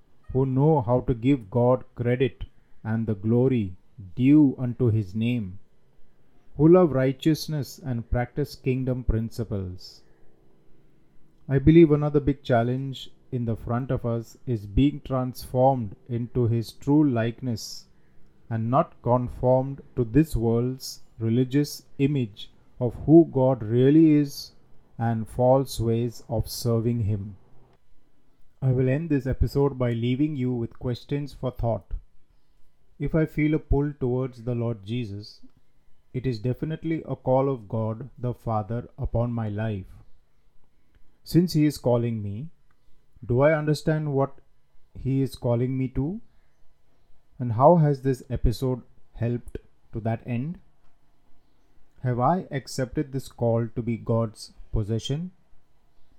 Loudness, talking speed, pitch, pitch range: -25 LUFS, 130 wpm, 125 Hz, 115-140 Hz